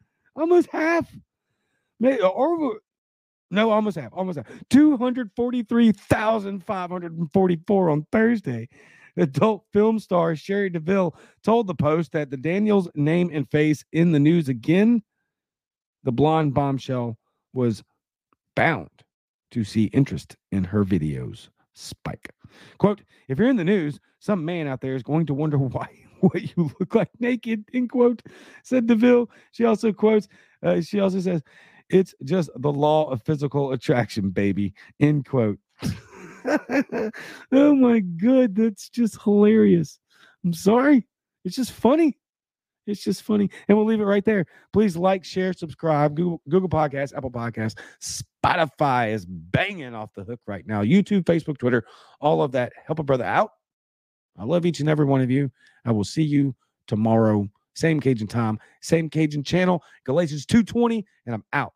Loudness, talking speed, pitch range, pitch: -22 LUFS, 150 wpm, 135-210 Hz, 170 Hz